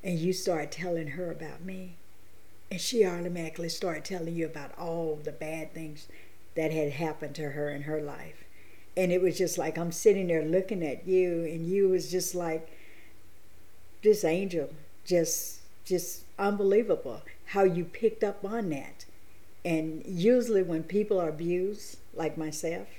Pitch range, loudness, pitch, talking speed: 155-185 Hz, -30 LUFS, 170 Hz, 160 wpm